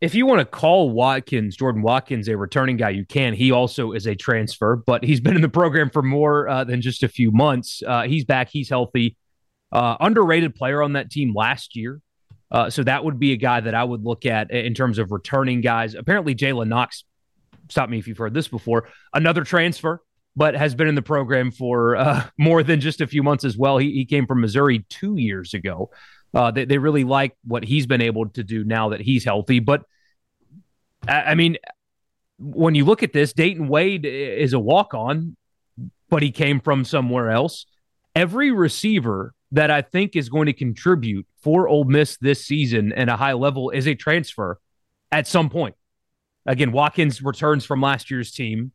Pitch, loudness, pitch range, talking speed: 135 Hz, -20 LUFS, 120-150 Hz, 200 wpm